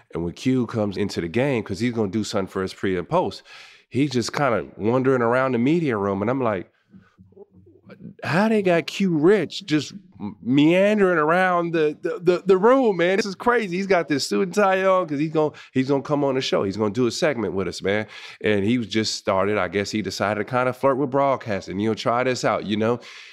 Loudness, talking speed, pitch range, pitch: -22 LUFS, 235 wpm, 110-170 Hz, 130 Hz